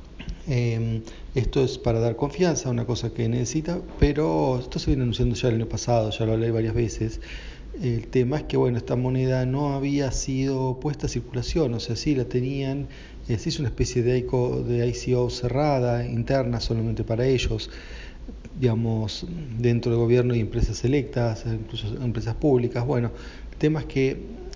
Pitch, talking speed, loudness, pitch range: 120 Hz, 175 wpm, -25 LUFS, 115-135 Hz